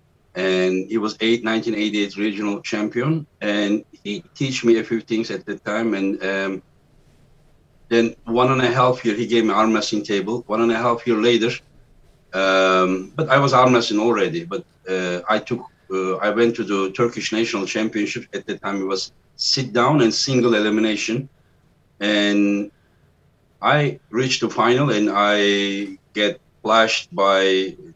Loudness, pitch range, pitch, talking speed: -20 LUFS, 100-120 Hz, 110 Hz, 165 wpm